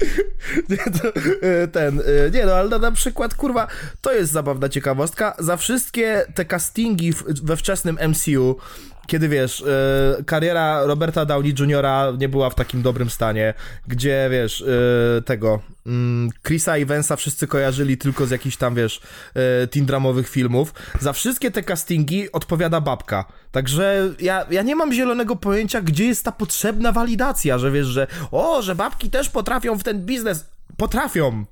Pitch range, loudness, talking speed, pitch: 135-200 Hz, -20 LUFS, 155 wpm, 155 Hz